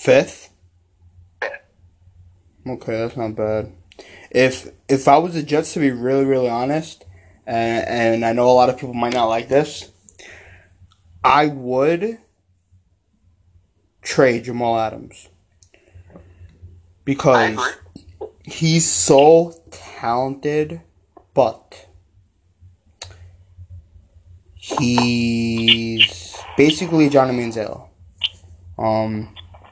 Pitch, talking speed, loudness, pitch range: 105 Hz, 85 wpm, -18 LUFS, 90-125 Hz